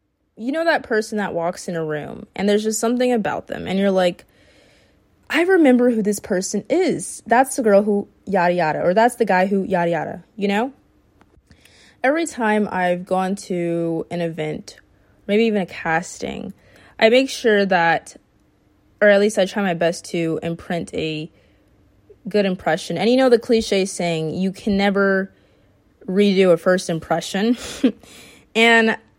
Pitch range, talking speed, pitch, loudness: 170-220 Hz, 165 wpm, 190 Hz, -19 LUFS